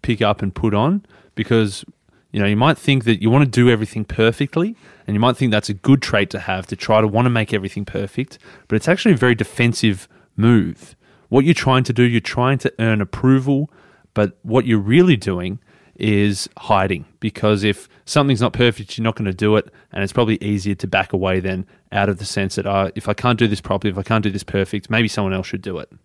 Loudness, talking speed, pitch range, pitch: -18 LUFS, 235 wpm, 100-125 Hz, 110 Hz